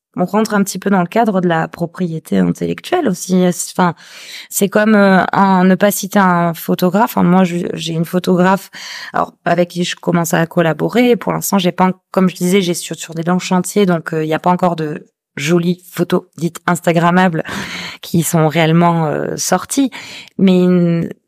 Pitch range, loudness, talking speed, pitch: 170-190 Hz, -14 LUFS, 190 wpm, 180 Hz